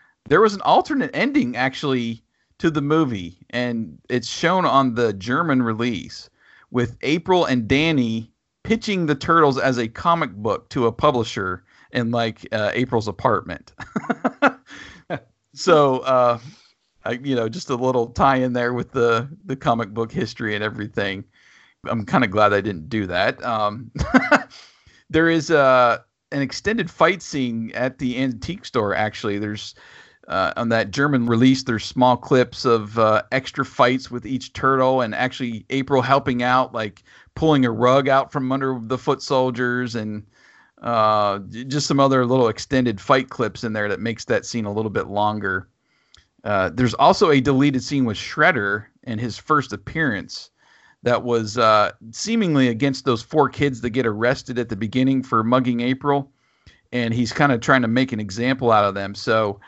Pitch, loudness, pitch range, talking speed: 125 Hz, -20 LUFS, 115-135 Hz, 165 wpm